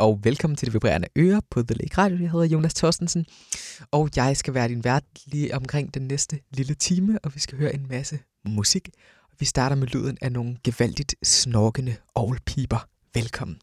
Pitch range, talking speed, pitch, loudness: 120-150 Hz, 190 wpm, 135 Hz, -24 LUFS